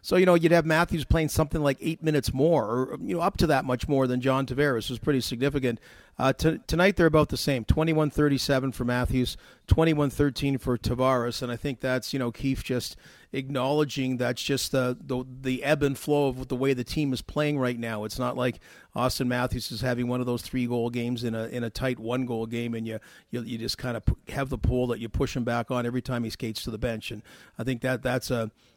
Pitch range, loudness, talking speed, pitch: 120-140 Hz, -27 LUFS, 245 wpm, 130 Hz